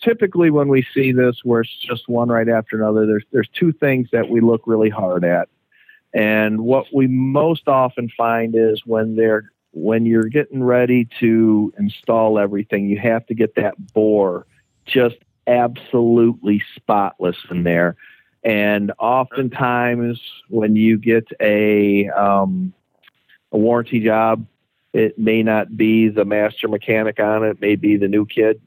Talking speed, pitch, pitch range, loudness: 155 wpm, 110 Hz, 105-120 Hz, -17 LUFS